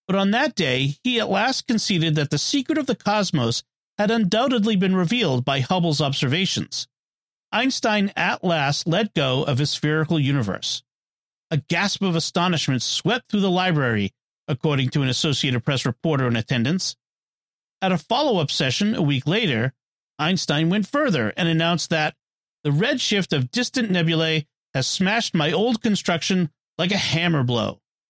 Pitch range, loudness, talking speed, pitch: 140-195 Hz, -22 LUFS, 160 wpm, 165 Hz